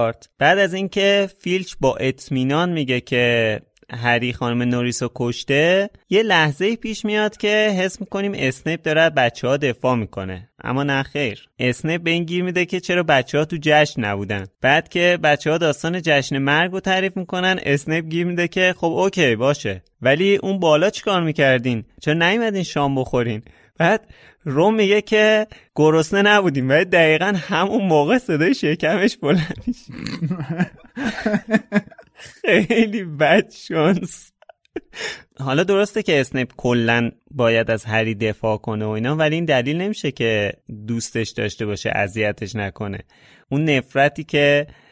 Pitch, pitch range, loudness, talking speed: 155 Hz, 125-190 Hz, -19 LUFS, 145 wpm